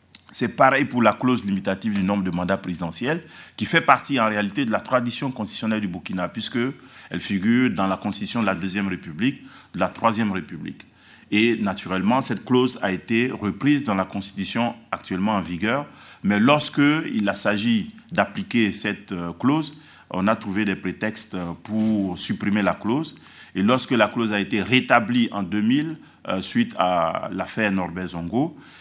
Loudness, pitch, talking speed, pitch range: -22 LUFS, 110 Hz, 165 wpm, 95-125 Hz